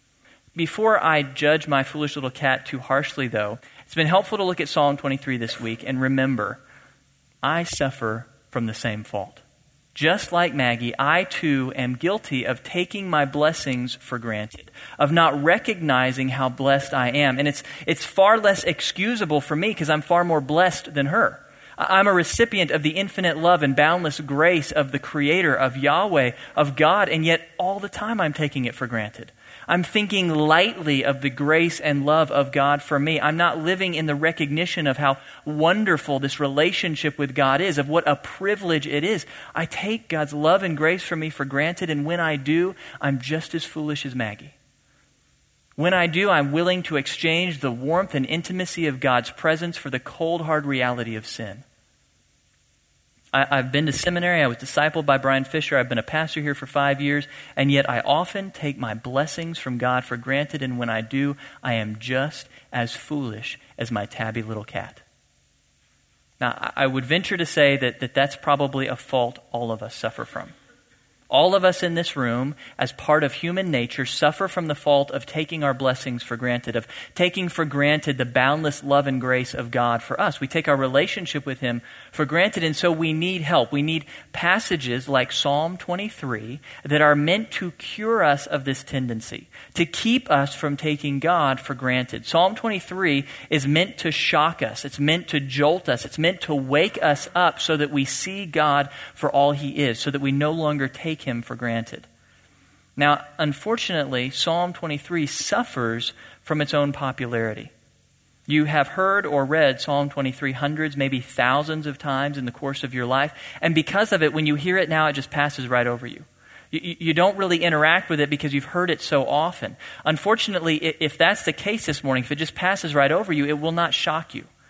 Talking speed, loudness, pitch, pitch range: 195 wpm, -22 LUFS, 145 Hz, 135-165 Hz